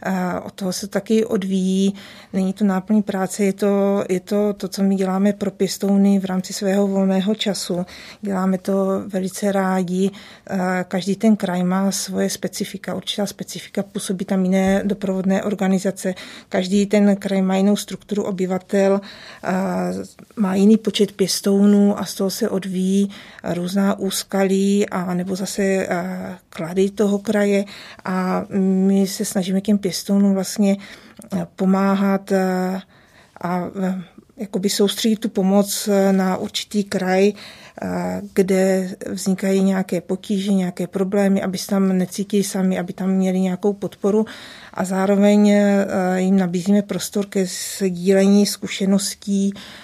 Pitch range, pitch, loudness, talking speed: 190-205 Hz, 195 Hz, -20 LUFS, 125 wpm